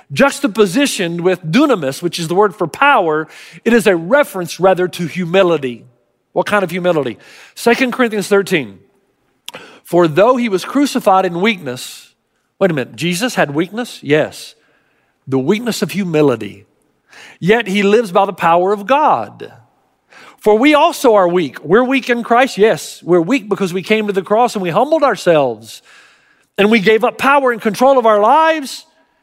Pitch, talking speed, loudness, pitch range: 200 Hz, 165 wpm, -14 LUFS, 175-245 Hz